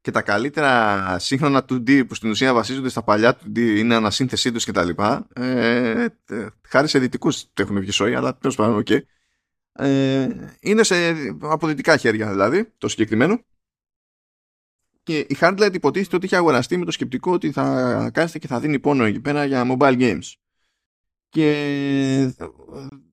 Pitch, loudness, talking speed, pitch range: 135 Hz, -20 LUFS, 155 wpm, 115-150 Hz